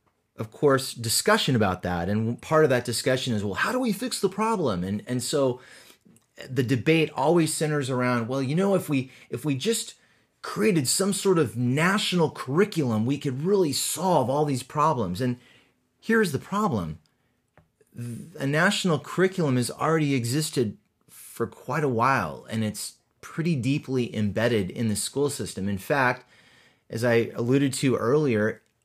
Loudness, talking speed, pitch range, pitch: -25 LUFS, 160 wpm, 120-165 Hz, 135 Hz